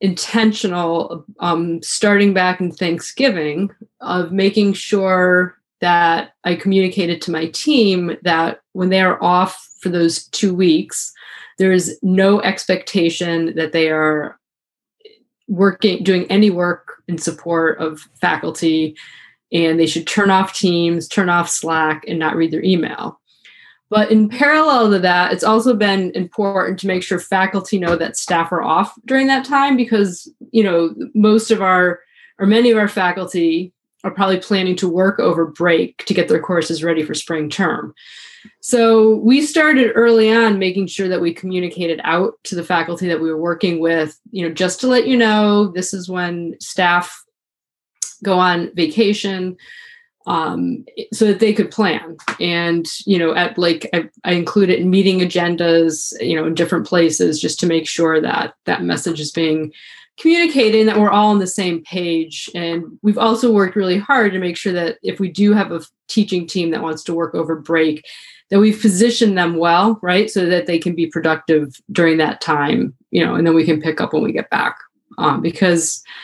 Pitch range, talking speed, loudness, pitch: 165-205 Hz, 175 wpm, -16 LUFS, 180 Hz